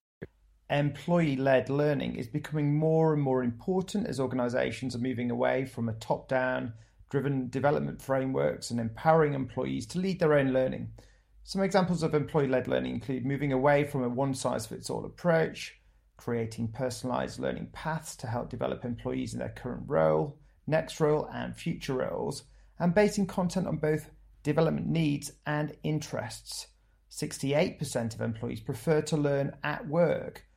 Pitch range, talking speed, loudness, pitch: 125-155 Hz, 145 wpm, -30 LUFS, 140 Hz